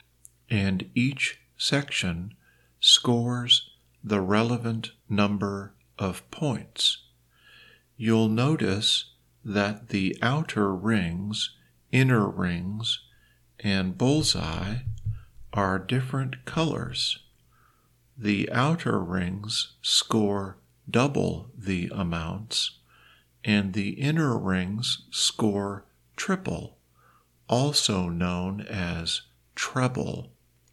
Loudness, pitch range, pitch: -26 LUFS, 90-120 Hz, 105 Hz